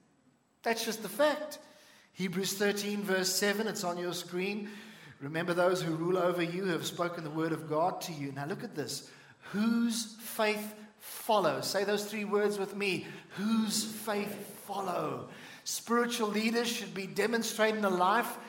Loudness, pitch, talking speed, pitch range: -32 LUFS, 205 Hz, 160 wpm, 175-220 Hz